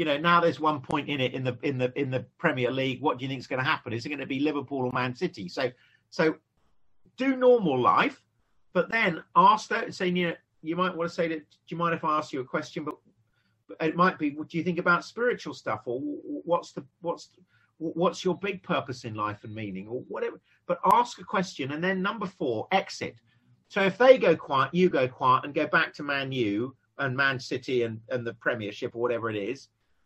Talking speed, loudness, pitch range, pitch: 240 wpm, -27 LUFS, 125-180 Hz, 155 Hz